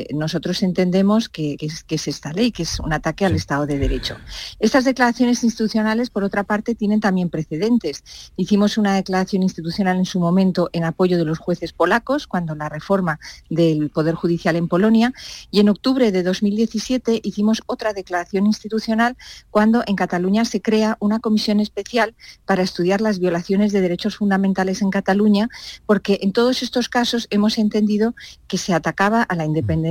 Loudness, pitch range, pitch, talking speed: -19 LUFS, 175-220 Hz, 200 Hz, 175 wpm